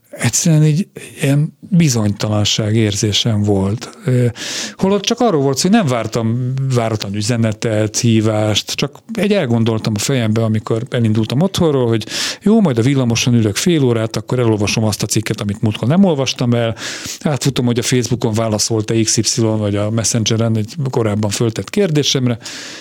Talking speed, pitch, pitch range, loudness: 145 wpm, 115 Hz, 110-140 Hz, -15 LUFS